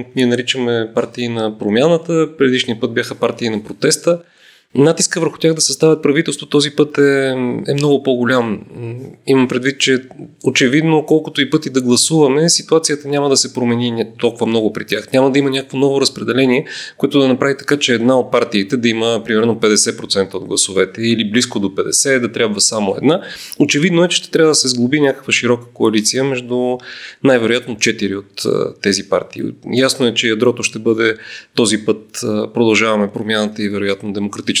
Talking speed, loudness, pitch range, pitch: 170 wpm, -15 LUFS, 115-140 Hz, 125 Hz